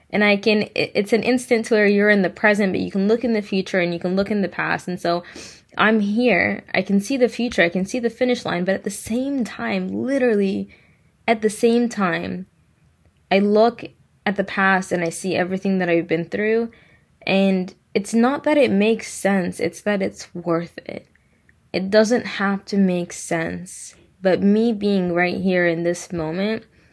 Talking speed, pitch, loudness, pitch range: 200 wpm, 200 Hz, -20 LUFS, 180-220 Hz